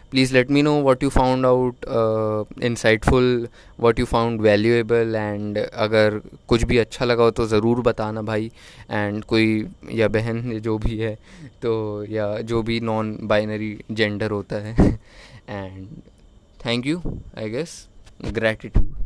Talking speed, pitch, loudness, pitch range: 145 wpm, 110 Hz, -21 LUFS, 105-120 Hz